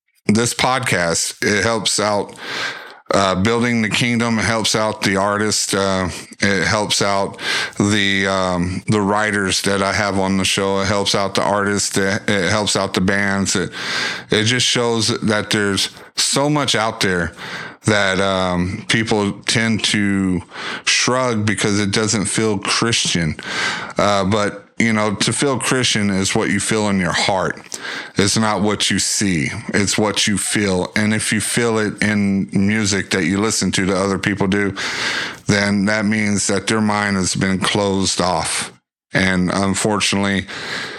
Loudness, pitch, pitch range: -17 LUFS, 100 Hz, 95-110 Hz